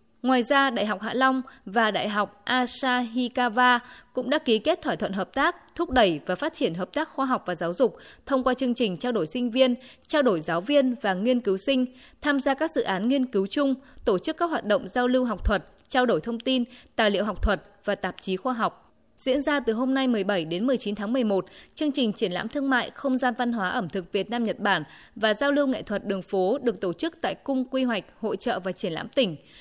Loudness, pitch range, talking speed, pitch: -26 LUFS, 205-265 Hz, 245 wpm, 245 Hz